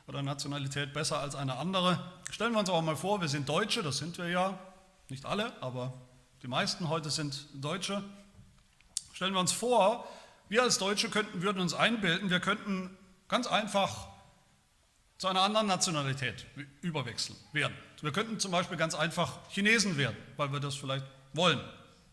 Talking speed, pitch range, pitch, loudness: 165 wpm, 140-190 Hz, 170 Hz, -32 LUFS